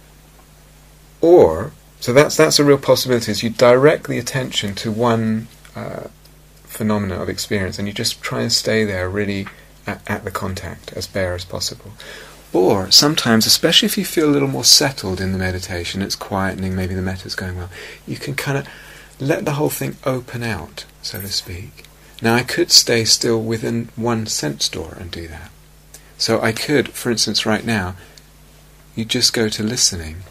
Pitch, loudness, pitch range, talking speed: 110 Hz, -17 LUFS, 95-120 Hz, 180 wpm